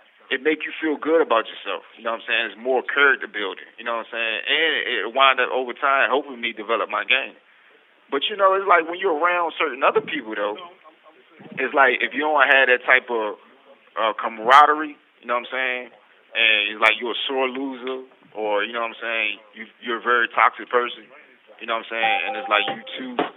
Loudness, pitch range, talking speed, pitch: -20 LUFS, 120-175 Hz, 230 wpm, 135 Hz